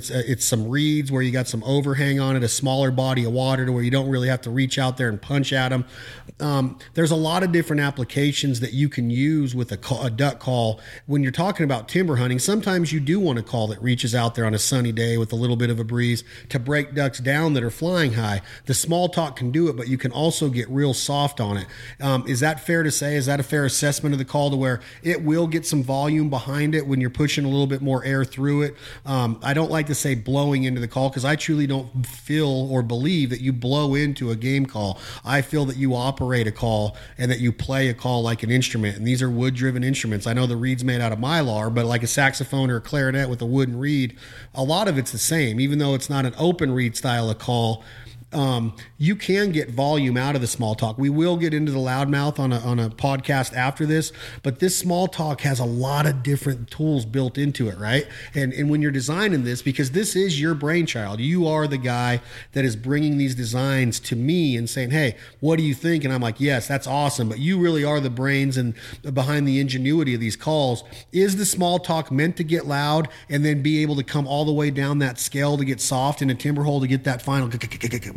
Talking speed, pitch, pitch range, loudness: 250 wpm, 135 Hz, 125-145 Hz, -22 LUFS